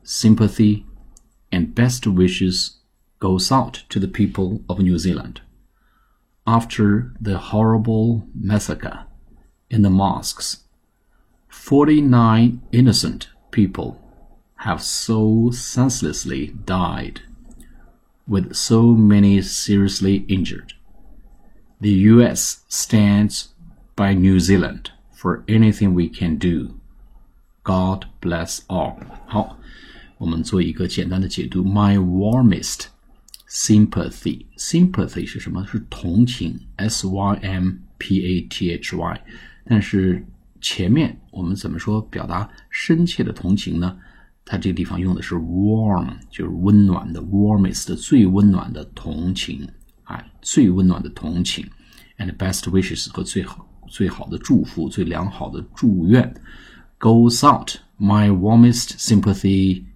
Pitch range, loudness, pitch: 90-110 Hz, -18 LUFS, 100 Hz